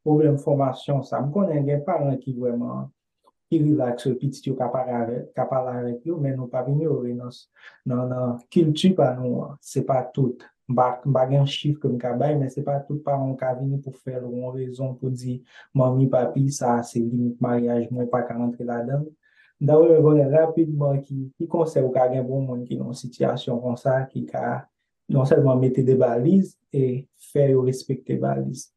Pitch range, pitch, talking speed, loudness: 125-140 Hz, 130 Hz, 190 wpm, -23 LUFS